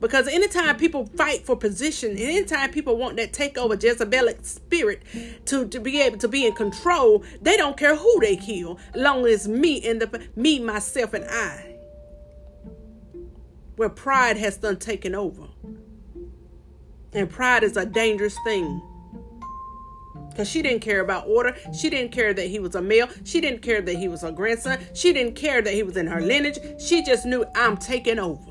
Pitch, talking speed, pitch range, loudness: 230 Hz, 185 wpm, 195-270 Hz, -22 LUFS